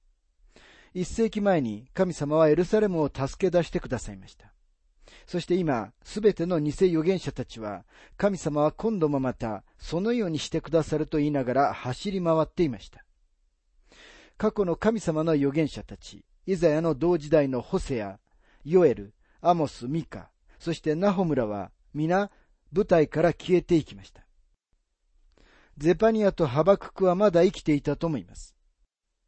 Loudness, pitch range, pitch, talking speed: -26 LUFS, 115-180 Hz, 155 Hz, 295 characters per minute